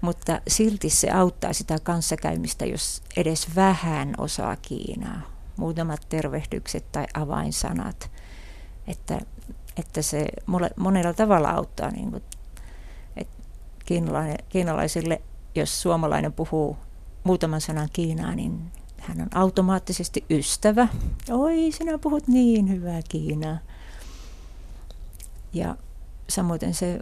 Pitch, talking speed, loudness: 160 Hz, 100 wpm, -25 LUFS